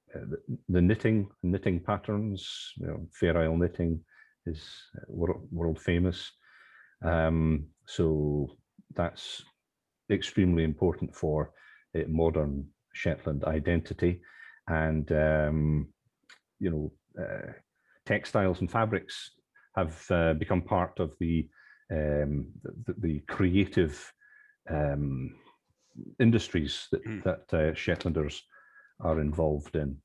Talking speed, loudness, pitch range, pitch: 95 wpm, -30 LUFS, 75-90 Hz, 80 Hz